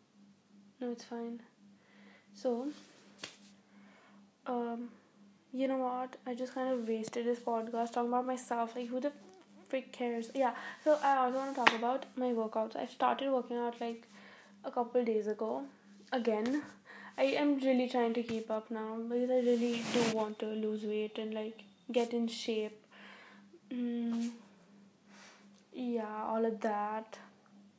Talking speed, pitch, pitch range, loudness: 150 wpm, 235 Hz, 215-250 Hz, -35 LUFS